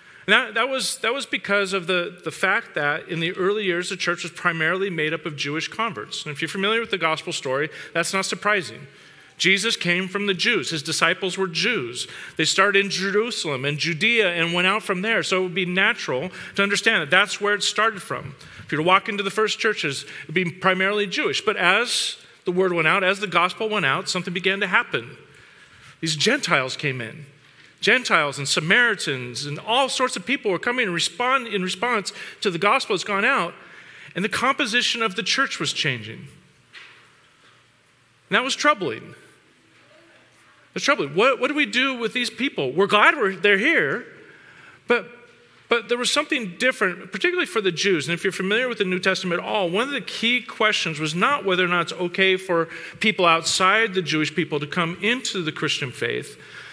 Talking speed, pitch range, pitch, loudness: 205 wpm, 165-220 Hz, 190 Hz, -21 LUFS